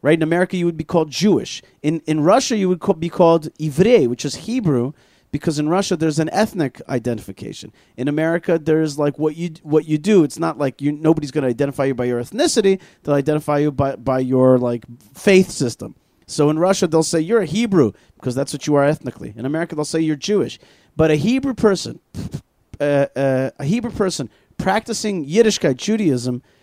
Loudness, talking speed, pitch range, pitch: -18 LUFS, 205 wpm, 135-180 Hz, 155 Hz